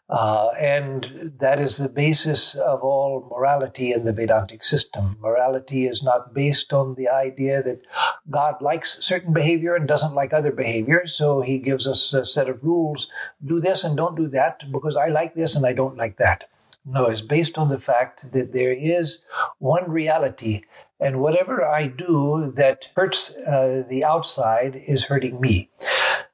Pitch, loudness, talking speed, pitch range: 140 Hz, -21 LUFS, 175 wpm, 130-155 Hz